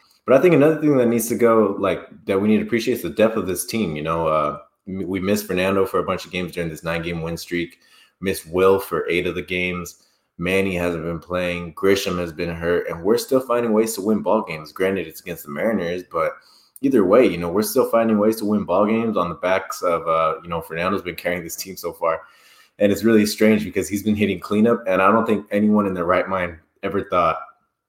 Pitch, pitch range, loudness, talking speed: 95 Hz, 85-105 Hz, -20 LUFS, 245 wpm